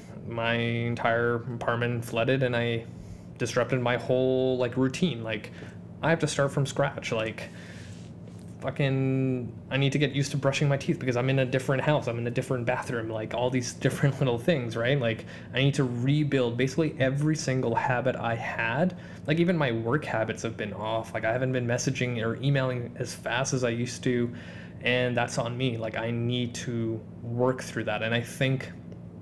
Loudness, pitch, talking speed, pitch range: -28 LUFS, 125 Hz, 190 wpm, 115-135 Hz